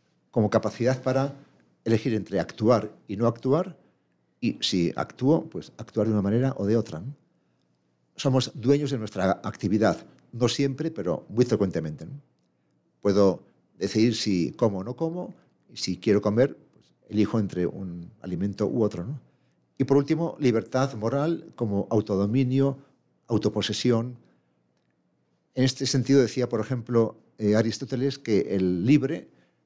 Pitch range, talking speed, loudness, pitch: 100-135 Hz, 140 wpm, -26 LUFS, 115 Hz